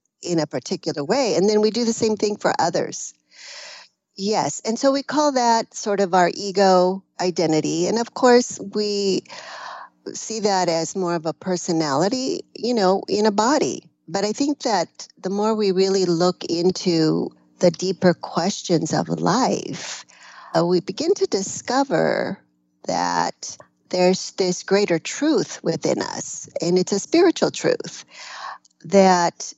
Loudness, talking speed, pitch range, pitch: -21 LUFS, 150 wpm, 175-225 Hz, 195 Hz